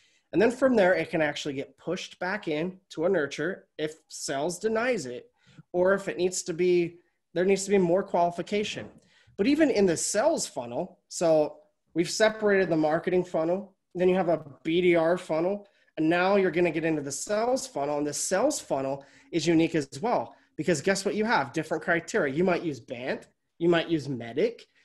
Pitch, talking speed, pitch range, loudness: 175 Hz, 195 wpm, 160-195 Hz, -27 LUFS